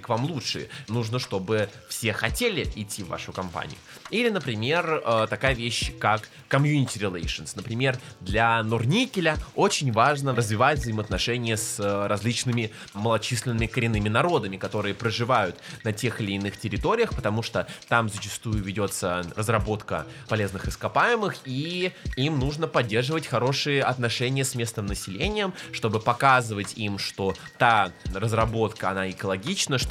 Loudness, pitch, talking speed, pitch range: -26 LUFS, 115 Hz, 125 wpm, 105-135 Hz